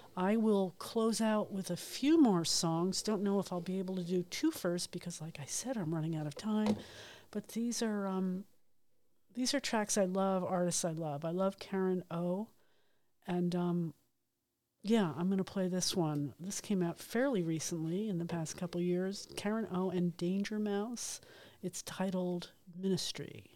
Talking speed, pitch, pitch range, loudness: 185 wpm, 185 Hz, 175-205 Hz, -35 LUFS